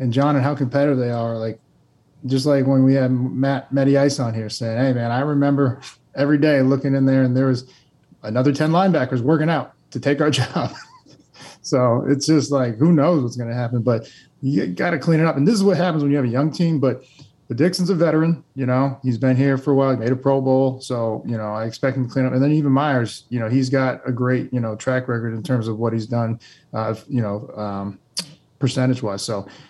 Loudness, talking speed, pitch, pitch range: -20 LUFS, 245 wpm, 135 Hz, 120-145 Hz